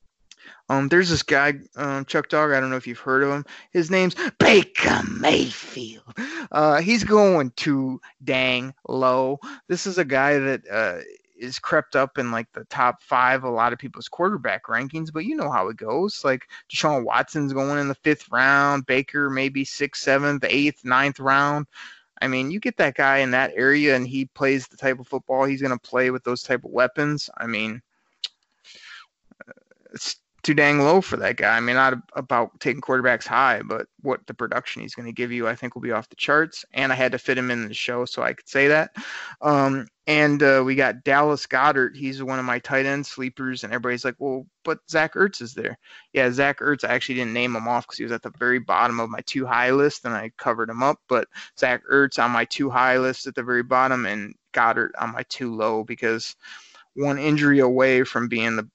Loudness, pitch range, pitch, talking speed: -22 LUFS, 125-145 Hz, 135 Hz, 215 wpm